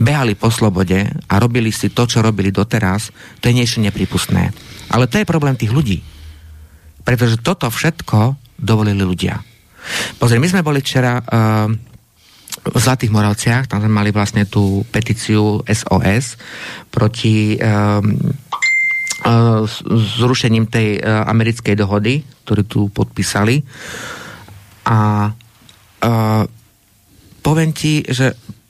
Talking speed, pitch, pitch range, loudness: 120 wpm, 110 Hz, 105-125 Hz, -15 LUFS